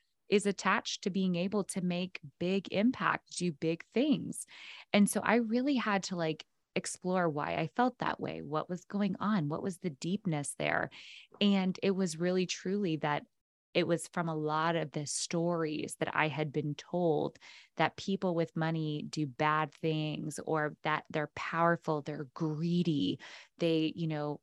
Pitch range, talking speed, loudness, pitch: 155-190 Hz, 170 wpm, -33 LUFS, 170 Hz